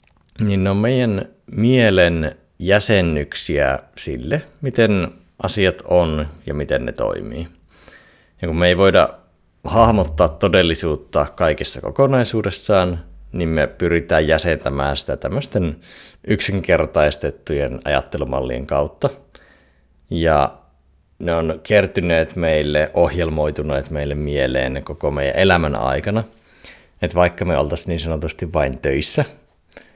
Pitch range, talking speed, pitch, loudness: 75-95 Hz, 105 wpm, 85 Hz, -18 LUFS